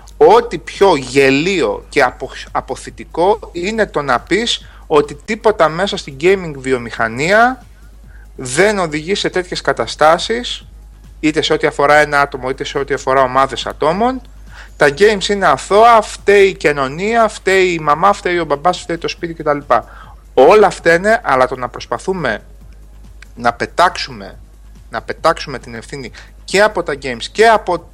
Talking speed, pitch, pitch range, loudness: 150 wpm, 175 Hz, 145-210 Hz, -14 LUFS